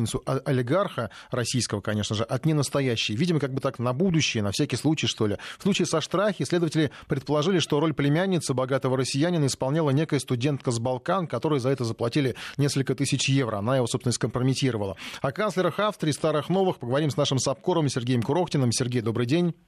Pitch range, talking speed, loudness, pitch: 125-155 Hz, 180 wpm, -25 LUFS, 135 Hz